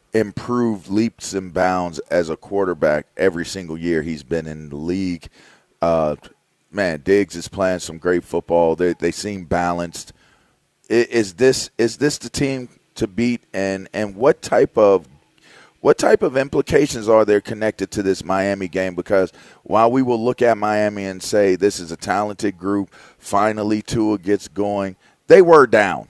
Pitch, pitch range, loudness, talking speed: 100 Hz, 90-110 Hz, -19 LUFS, 170 wpm